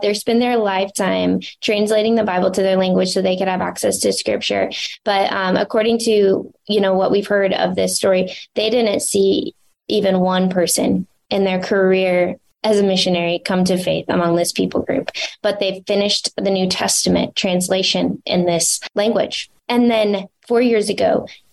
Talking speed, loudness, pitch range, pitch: 175 wpm, -17 LUFS, 185-210 Hz, 195 Hz